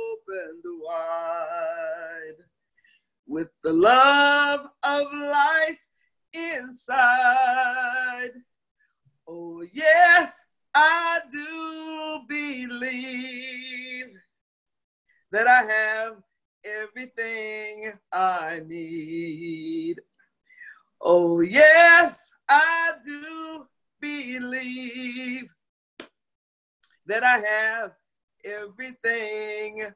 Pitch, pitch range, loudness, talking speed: 255 Hz, 215-320 Hz, -21 LUFS, 55 wpm